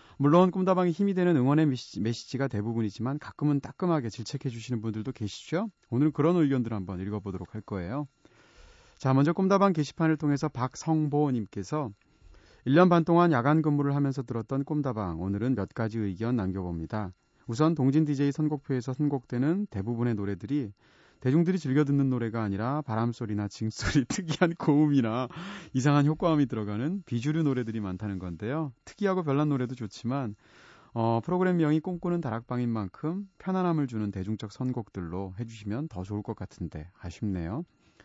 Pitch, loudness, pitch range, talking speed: 130 Hz, -28 LUFS, 110-155 Hz, 385 characters per minute